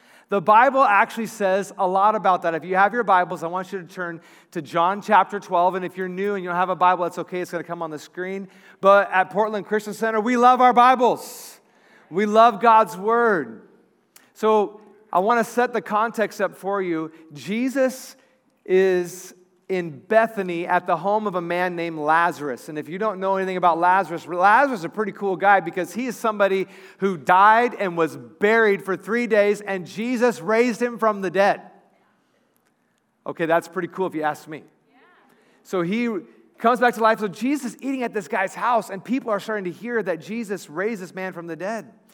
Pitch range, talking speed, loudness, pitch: 180-225 Hz, 205 wpm, -21 LUFS, 195 Hz